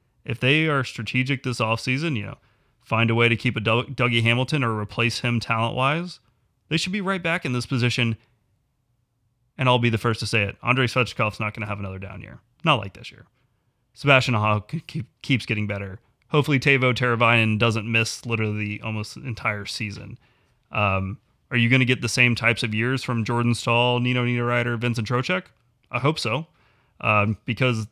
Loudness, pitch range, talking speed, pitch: -22 LUFS, 115-125 Hz, 190 wpm, 120 Hz